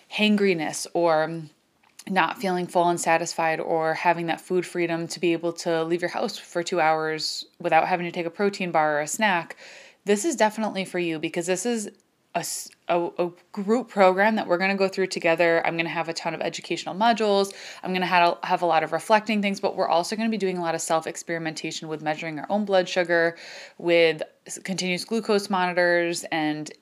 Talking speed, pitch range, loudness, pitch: 210 wpm, 165-195 Hz, -24 LUFS, 175 Hz